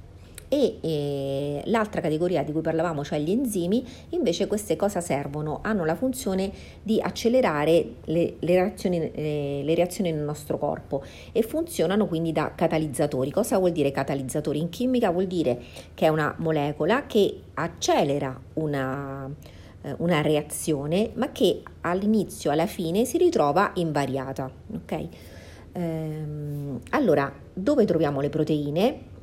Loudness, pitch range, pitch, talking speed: -25 LUFS, 145-195 Hz, 160 Hz, 135 wpm